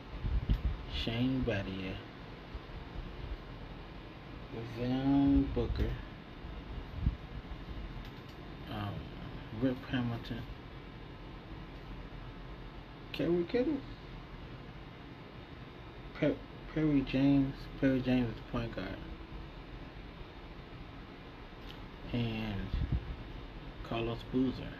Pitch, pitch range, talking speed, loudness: 125 Hz, 100-140 Hz, 50 wpm, -36 LUFS